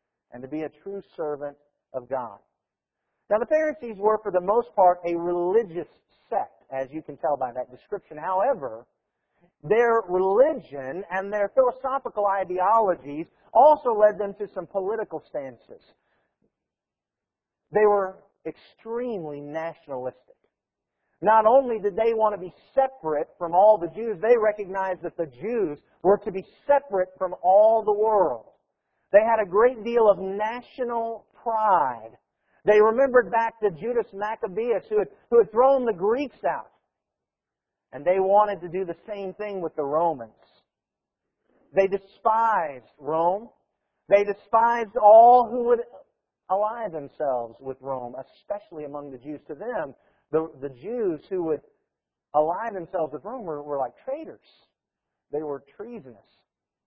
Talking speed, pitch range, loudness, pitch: 145 wpm, 160-225 Hz, -24 LUFS, 200 Hz